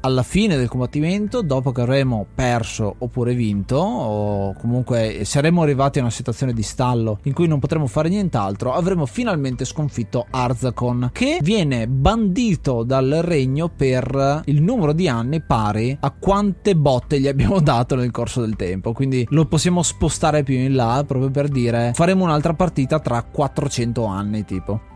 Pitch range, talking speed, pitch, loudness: 120-155 Hz, 160 wpm, 135 Hz, -19 LUFS